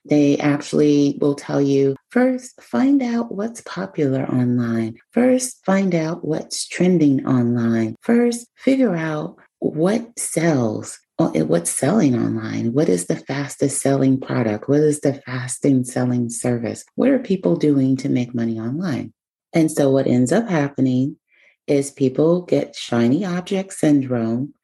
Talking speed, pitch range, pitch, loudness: 140 wpm, 125-180 Hz, 145 Hz, -19 LUFS